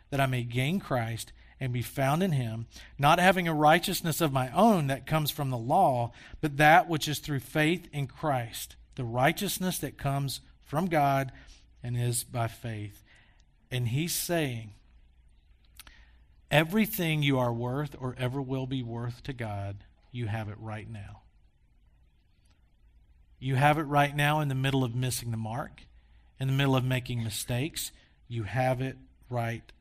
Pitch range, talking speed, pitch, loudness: 115-145 Hz, 165 wpm, 130 Hz, -29 LUFS